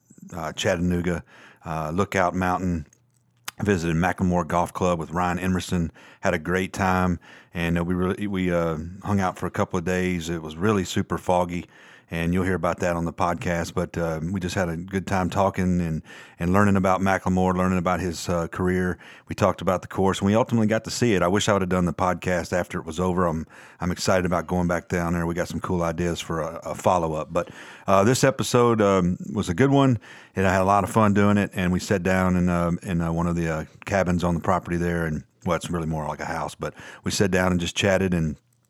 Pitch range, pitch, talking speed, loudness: 85-95 Hz, 90 Hz, 240 wpm, -24 LUFS